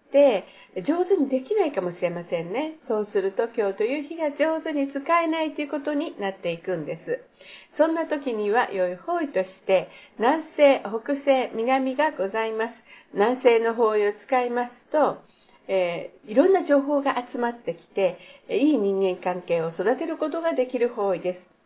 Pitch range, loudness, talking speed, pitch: 200-300 Hz, -24 LUFS, 330 characters per minute, 245 Hz